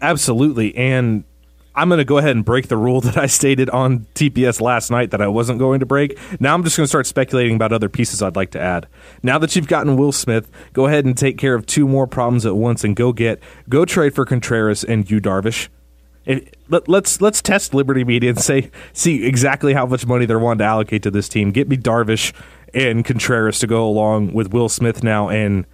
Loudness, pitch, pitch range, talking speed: -16 LUFS, 125 Hz, 110-135 Hz, 225 wpm